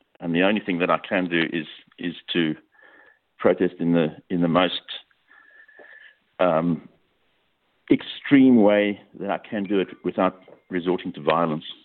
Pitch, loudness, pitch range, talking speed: 90 Hz, -23 LUFS, 85-105 Hz, 145 wpm